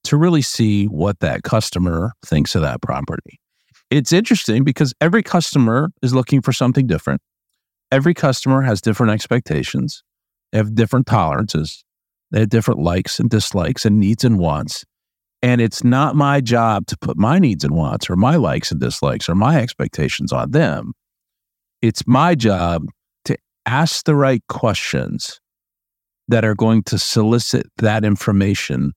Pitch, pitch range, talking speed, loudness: 115 Hz, 105-135 Hz, 155 wpm, -17 LUFS